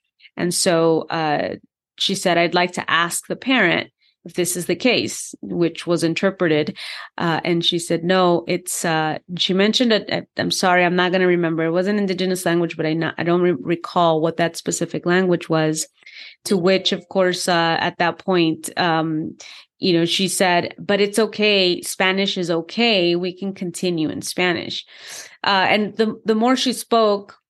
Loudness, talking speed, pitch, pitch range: -19 LUFS, 185 wpm, 180 Hz, 170-195 Hz